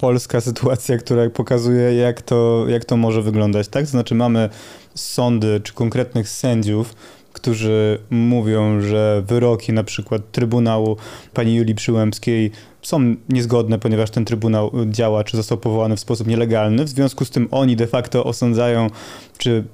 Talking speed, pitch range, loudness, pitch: 145 wpm, 110-120 Hz, -18 LUFS, 115 Hz